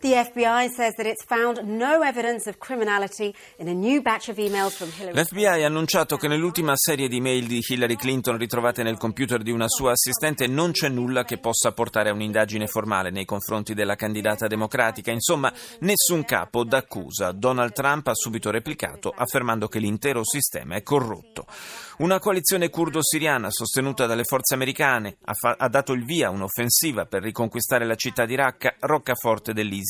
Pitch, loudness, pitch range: 130 Hz, -23 LUFS, 115-170 Hz